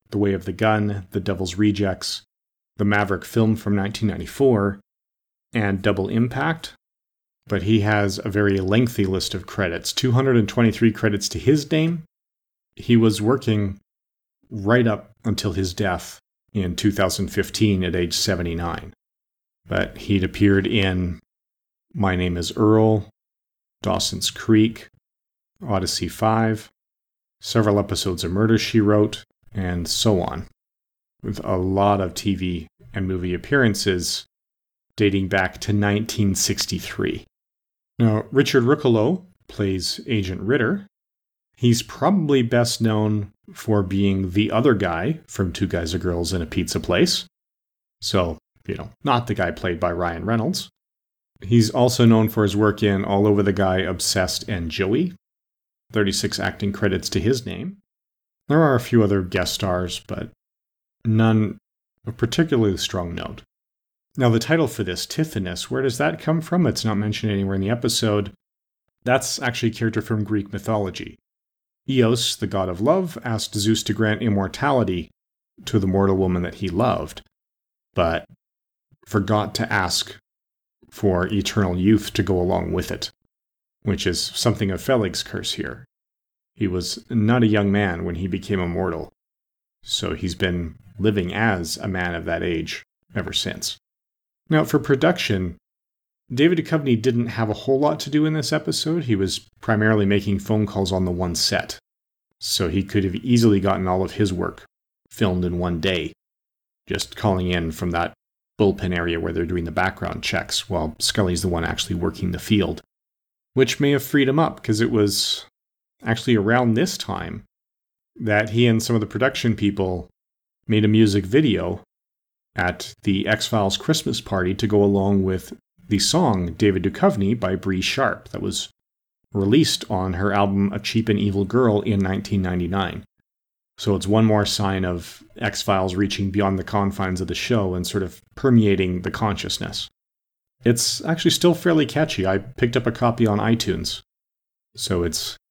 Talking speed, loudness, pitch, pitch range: 155 wpm, -21 LUFS, 105 Hz, 95-115 Hz